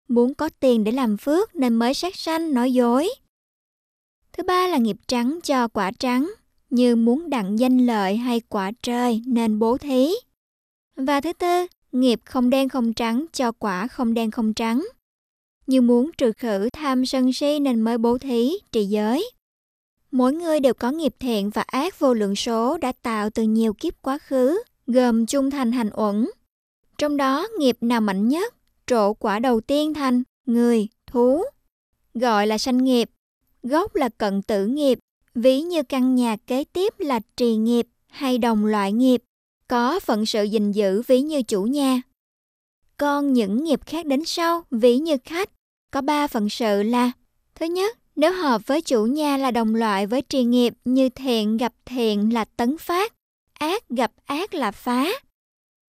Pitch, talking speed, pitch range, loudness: 255 Hz, 175 wpm, 230-285 Hz, -22 LUFS